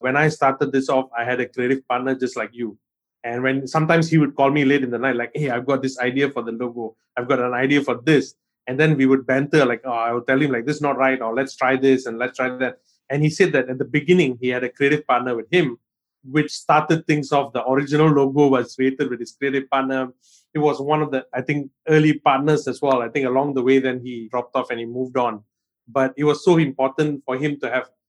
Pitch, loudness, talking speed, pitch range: 135 Hz, -20 LUFS, 265 wpm, 125-145 Hz